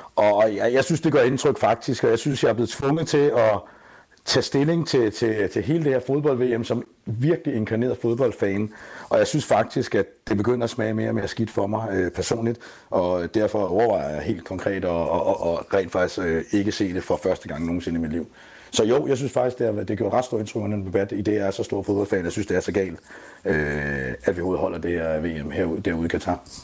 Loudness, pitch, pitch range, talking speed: -23 LUFS, 105 Hz, 90-125 Hz, 235 wpm